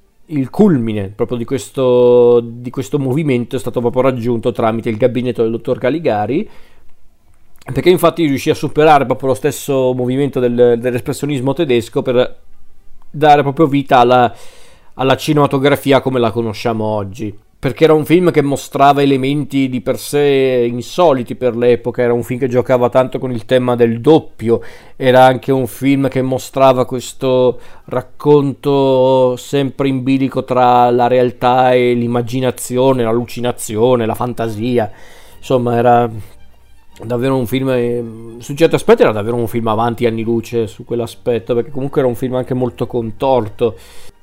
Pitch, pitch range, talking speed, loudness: 125 Hz, 120-135 Hz, 150 wpm, -14 LUFS